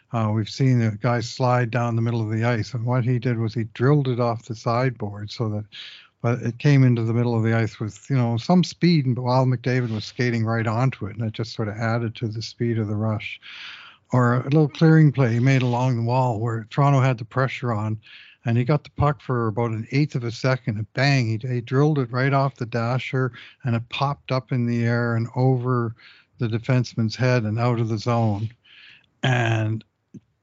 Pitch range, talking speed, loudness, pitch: 115-130 Hz, 225 wpm, -22 LUFS, 120 Hz